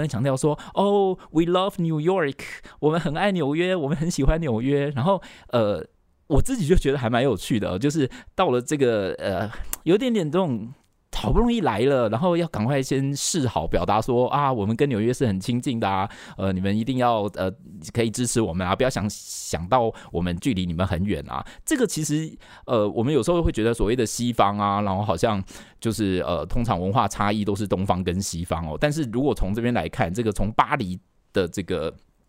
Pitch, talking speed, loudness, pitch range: 120 Hz, 320 characters per minute, -24 LUFS, 100-155 Hz